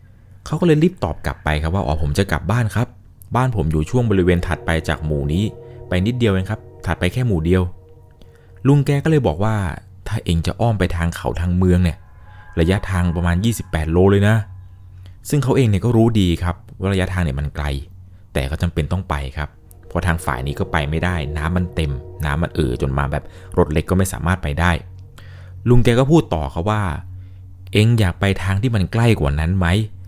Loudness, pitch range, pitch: -19 LUFS, 85-105 Hz, 95 Hz